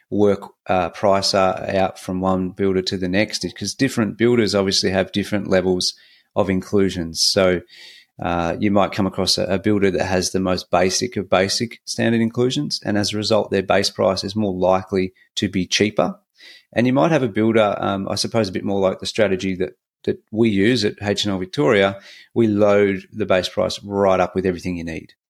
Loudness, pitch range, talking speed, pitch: -19 LUFS, 95-105 Hz, 195 wpm, 100 Hz